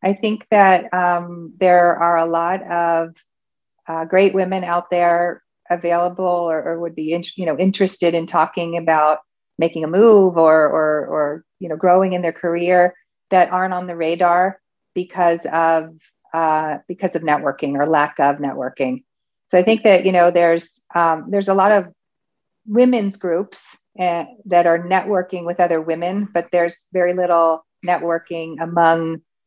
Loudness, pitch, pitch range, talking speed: -17 LUFS, 175 Hz, 165-185 Hz, 165 wpm